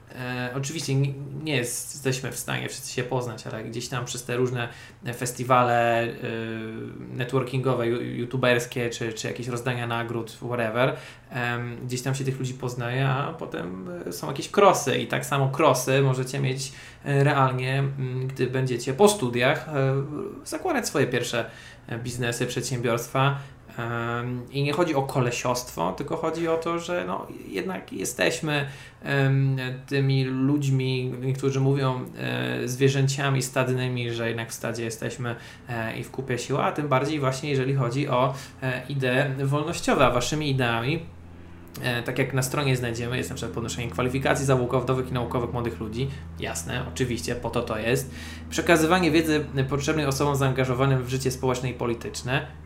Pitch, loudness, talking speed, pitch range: 130 Hz, -26 LUFS, 145 wpm, 120-135 Hz